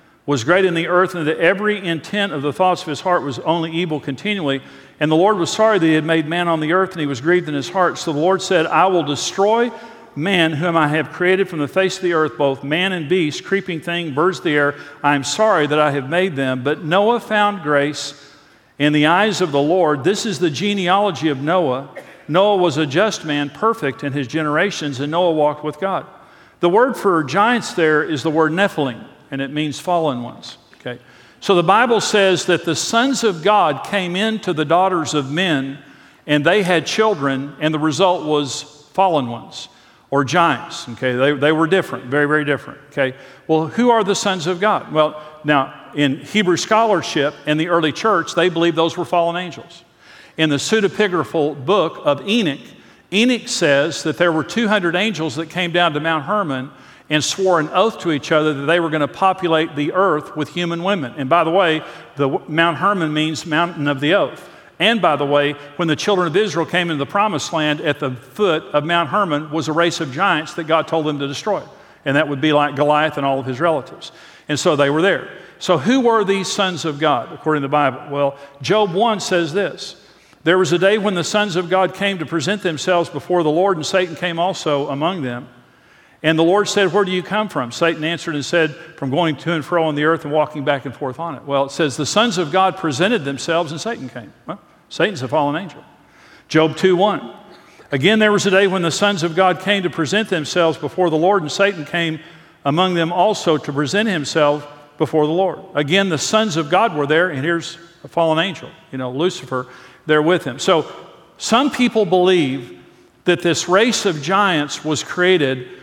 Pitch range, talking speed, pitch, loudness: 150-185 Hz, 215 wpm, 165 Hz, -17 LUFS